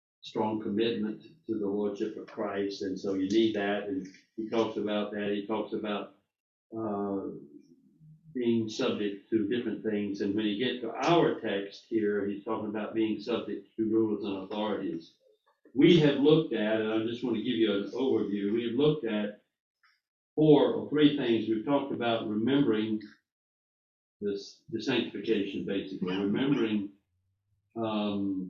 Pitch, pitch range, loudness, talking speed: 105 Hz, 100-115 Hz, -30 LUFS, 155 wpm